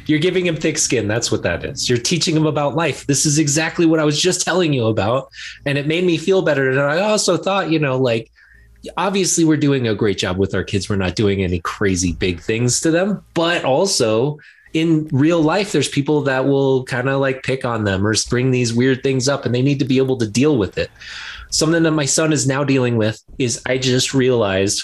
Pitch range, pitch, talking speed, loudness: 115-160 Hz, 135 Hz, 235 wpm, -17 LUFS